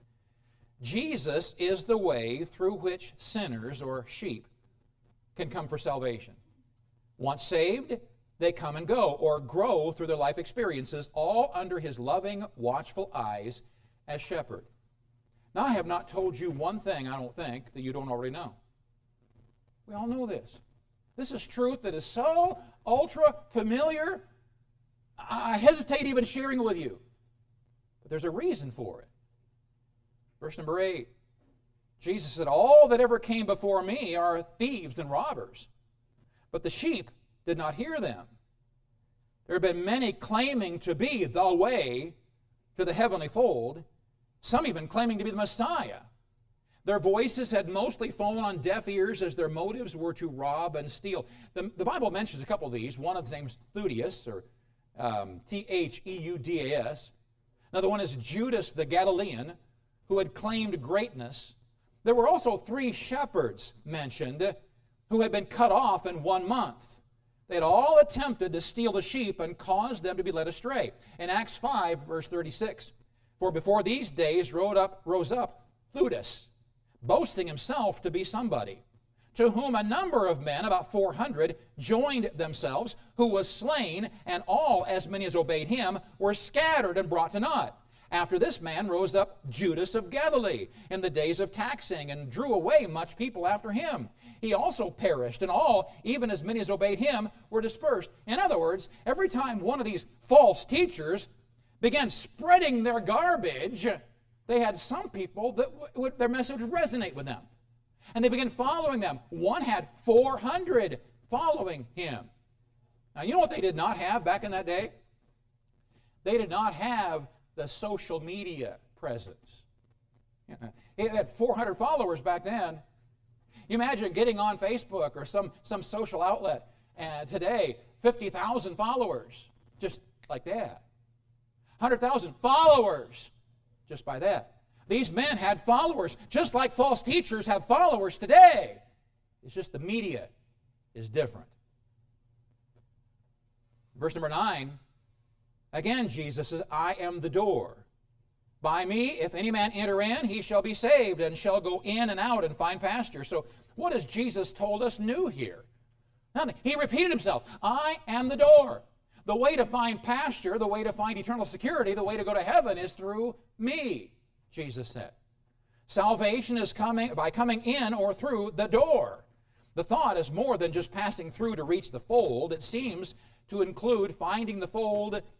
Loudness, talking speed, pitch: -29 LUFS, 160 wpm, 170 Hz